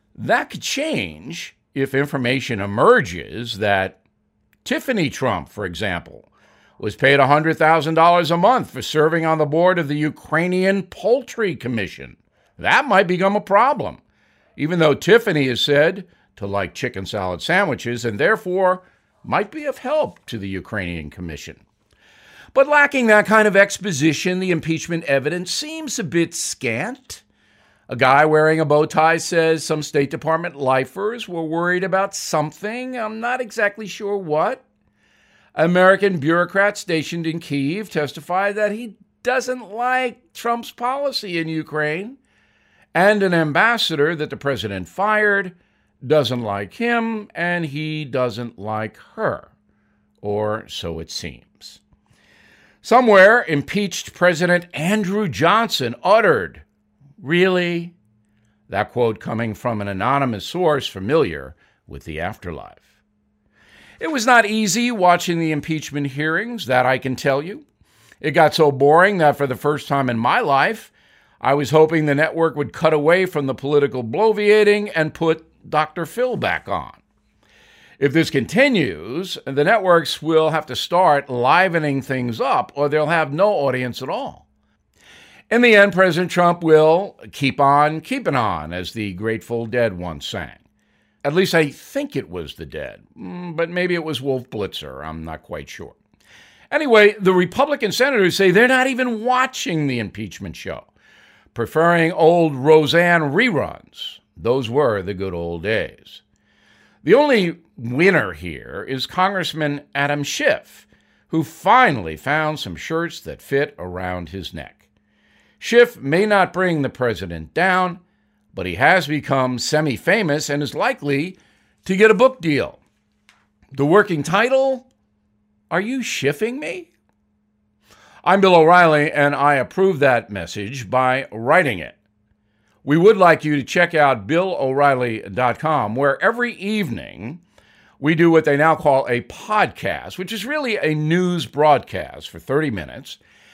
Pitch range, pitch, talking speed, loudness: 125-190 Hz, 155 Hz, 140 wpm, -18 LUFS